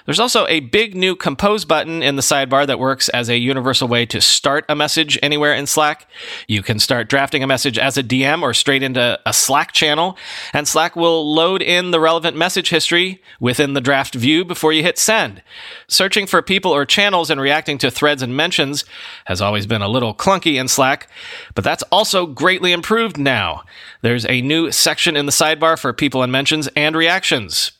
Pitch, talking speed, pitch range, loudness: 150 Hz, 200 wpm, 135-170 Hz, -15 LUFS